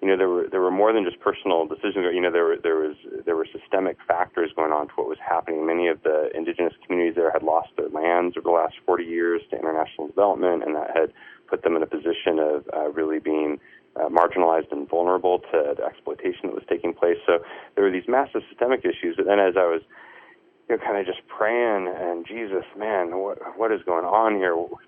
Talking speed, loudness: 230 wpm, -24 LUFS